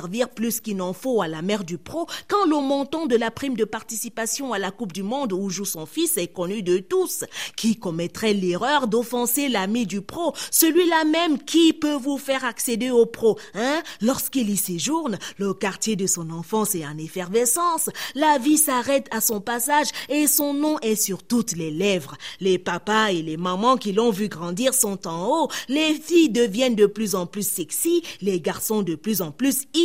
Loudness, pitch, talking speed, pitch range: -22 LUFS, 225 Hz, 195 wpm, 195-280 Hz